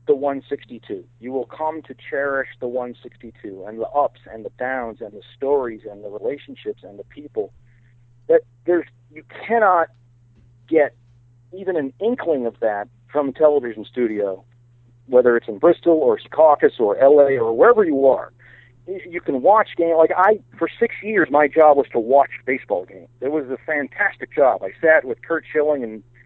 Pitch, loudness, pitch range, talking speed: 140 Hz, -19 LUFS, 120-165 Hz, 175 wpm